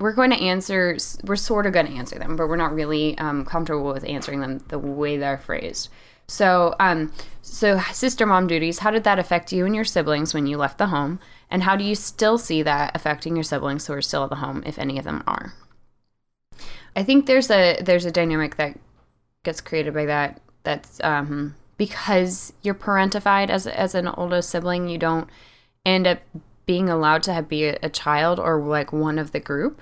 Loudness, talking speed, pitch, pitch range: -22 LUFS, 205 wpm, 165 Hz, 150-185 Hz